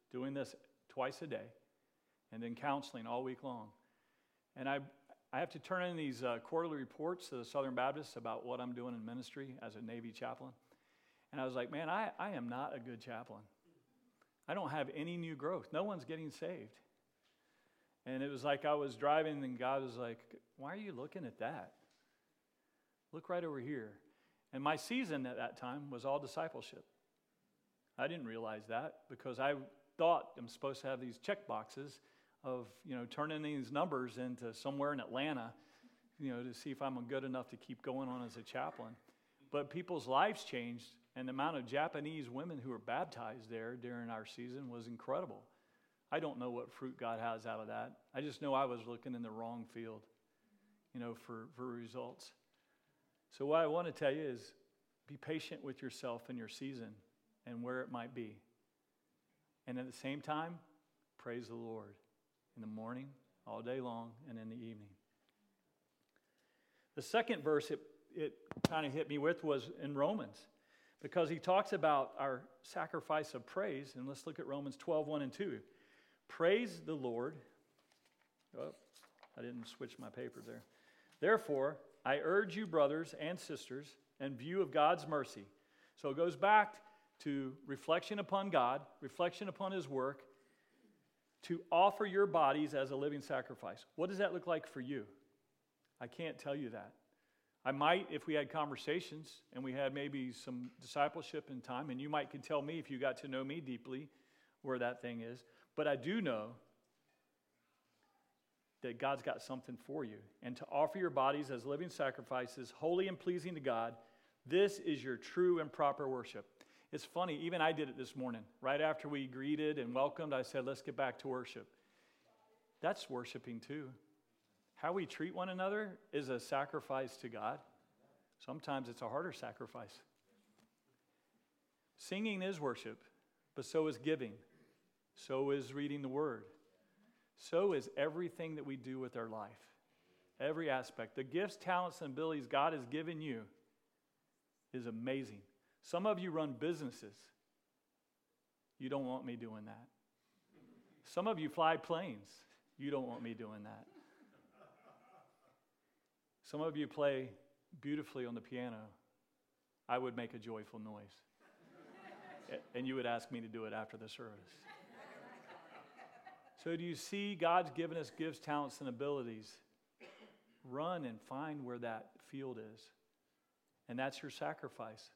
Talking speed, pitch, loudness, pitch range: 170 wpm, 135 Hz, -42 LUFS, 120-155 Hz